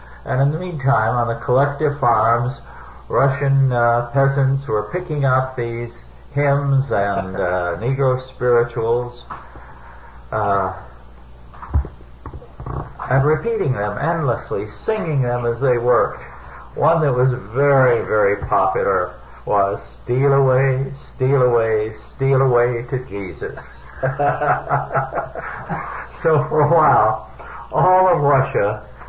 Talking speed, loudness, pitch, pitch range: 105 wpm, -19 LUFS, 125 Hz, 110-135 Hz